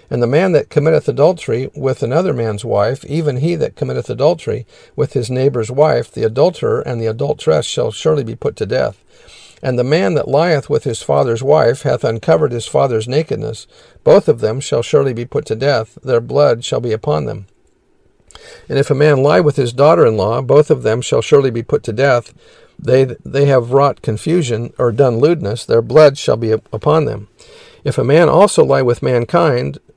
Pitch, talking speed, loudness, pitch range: 135 Hz, 200 wpm, -14 LUFS, 115-150 Hz